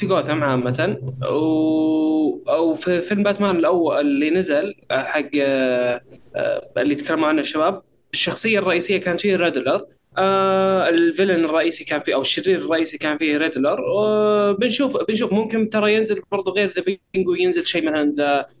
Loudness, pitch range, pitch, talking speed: -19 LUFS, 155-205 Hz, 180 Hz, 145 wpm